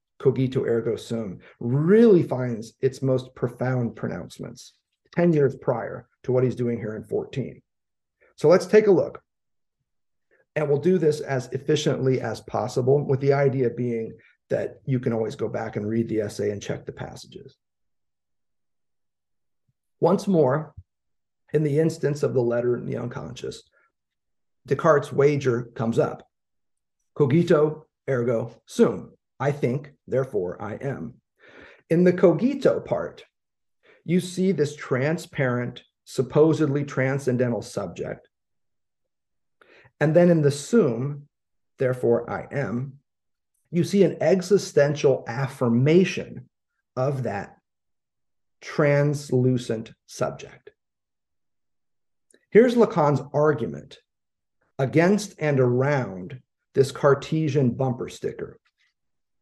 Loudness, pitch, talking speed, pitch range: -23 LUFS, 140 Hz, 110 wpm, 125-155 Hz